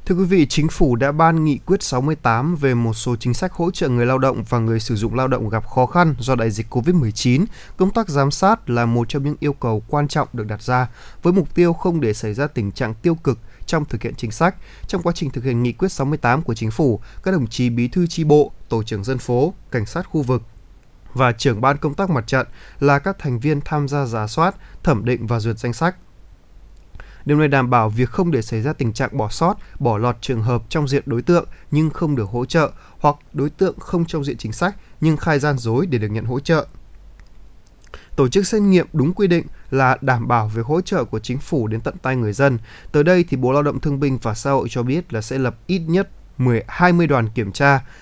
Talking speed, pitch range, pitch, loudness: 245 wpm, 115-160 Hz, 135 Hz, -19 LUFS